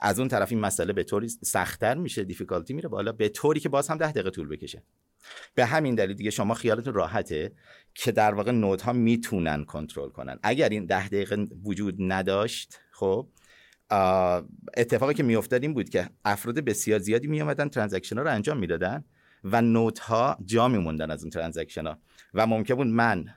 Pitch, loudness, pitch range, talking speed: 105 Hz, -27 LUFS, 95-120 Hz, 180 wpm